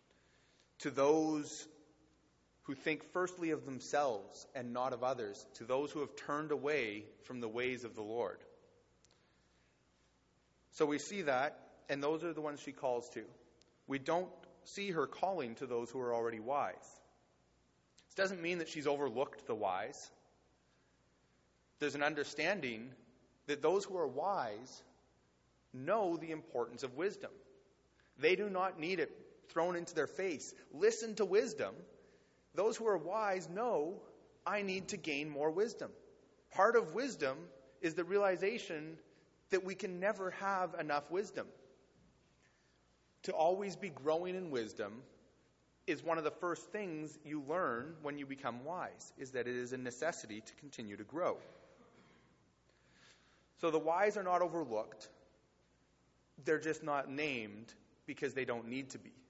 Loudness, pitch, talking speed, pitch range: -39 LUFS, 150 Hz, 150 wpm, 120-180 Hz